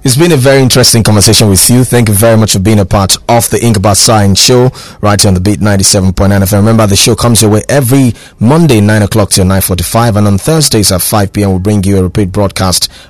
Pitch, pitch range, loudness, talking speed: 105 Hz, 100-120 Hz, -6 LUFS, 260 wpm